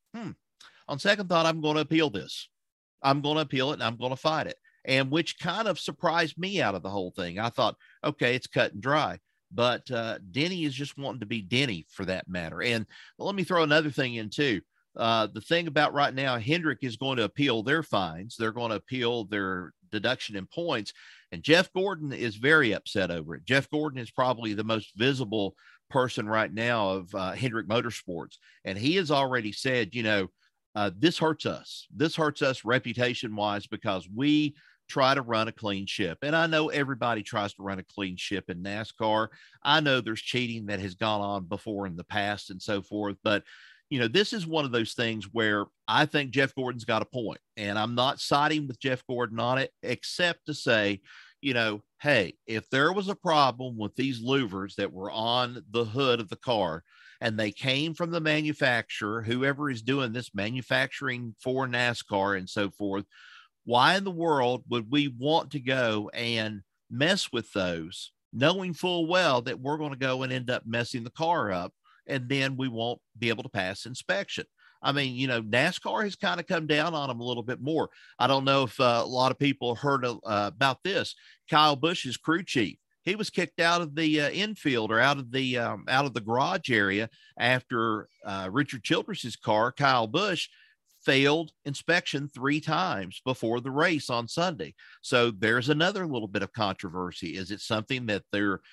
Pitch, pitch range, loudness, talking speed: 125 Hz, 110-150 Hz, -28 LUFS, 200 wpm